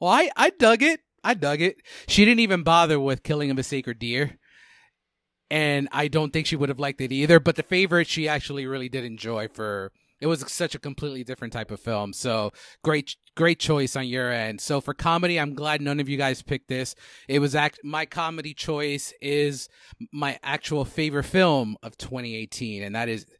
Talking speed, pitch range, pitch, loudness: 205 wpm, 130-155 Hz, 145 Hz, -24 LUFS